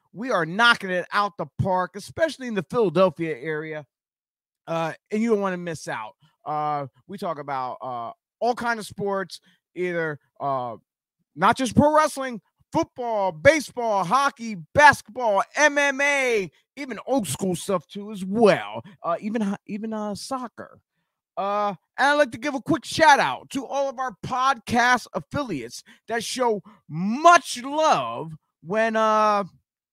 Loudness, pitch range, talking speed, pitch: -23 LUFS, 175-260 Hz, 150 wpm, 210 Hz